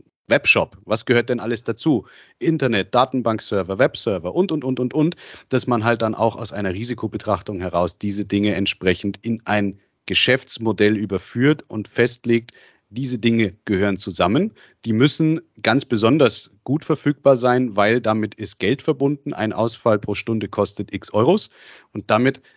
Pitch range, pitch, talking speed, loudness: 105-130 Hz, 115 Hz, 150 wpm, -20 LUFS